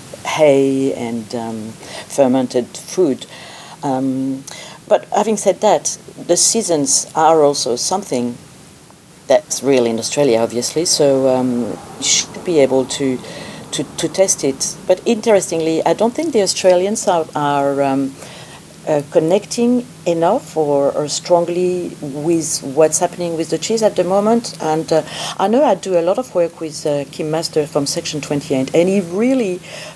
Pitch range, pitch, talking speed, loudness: 140-185 Hz, 160 Hz, 150 wpm, -16 LUFS